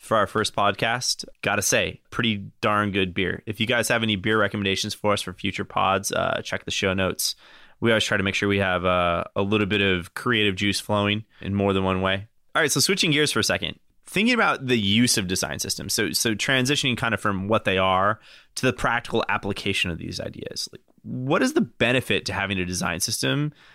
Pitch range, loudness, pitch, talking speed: 95-115 Hz, -23 LUFS, 105 Hz, 225 wpm